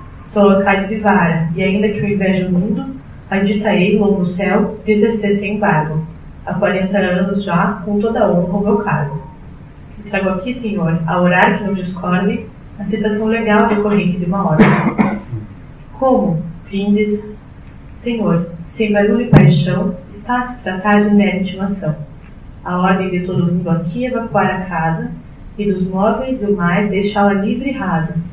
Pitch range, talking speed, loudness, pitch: 180-210 Hz, 170 wpm, -15 LUFS, 195 Hz